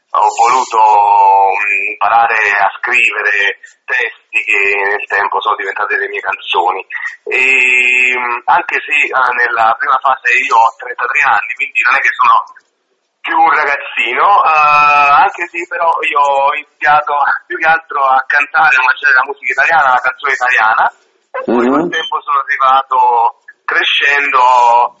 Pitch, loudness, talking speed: 160 Hz, -10 LUFS, 135 wpm